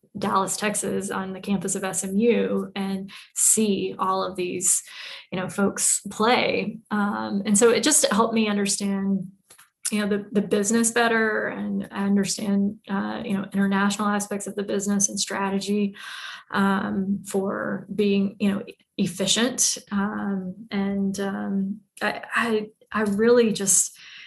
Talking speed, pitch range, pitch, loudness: 140 wpm, 195-215 Hz, 200 Hz, -23 LUFS